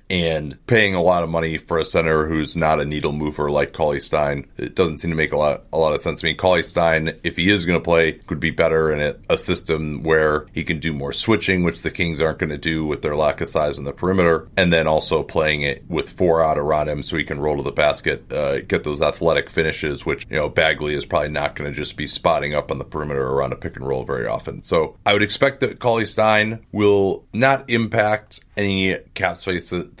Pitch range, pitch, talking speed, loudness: 75-95 Hz, 80 Hz, 250 wpm, -20 LUFS